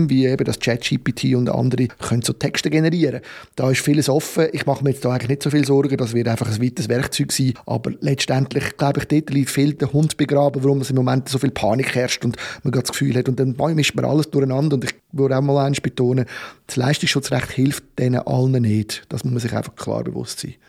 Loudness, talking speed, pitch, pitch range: -20 LUFS, 240 wpm, 135 Hz, 125-145 Hz